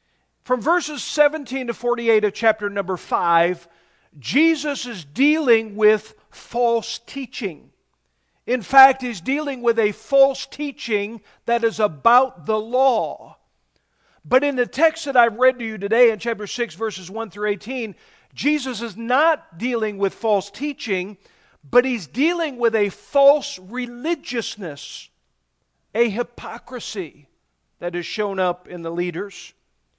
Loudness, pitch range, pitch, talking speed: -21 LUFS, 205-260 Hz, 235 Hz, 135 wpm